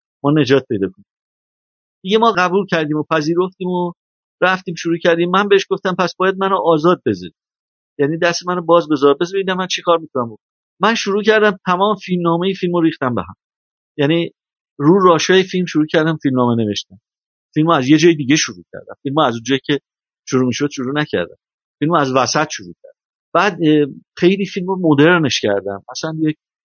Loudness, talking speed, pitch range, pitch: -16 LUFS, 185 wpm, 145-185 Hz, 165 Hz